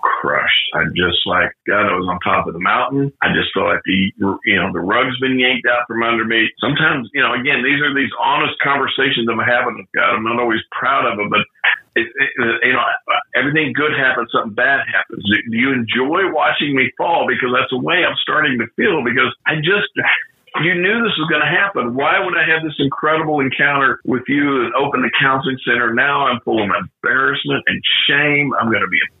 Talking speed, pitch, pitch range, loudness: 220 wpm, 130 Hz, 115-150 Hz, -15 LUFS